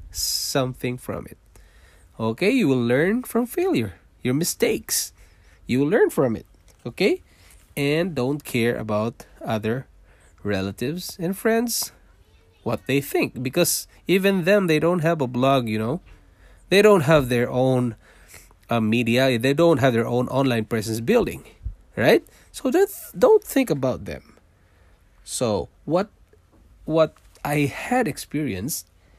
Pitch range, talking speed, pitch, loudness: 100-165 Hz, 140 wpm, 125 Hz, -22 LUFS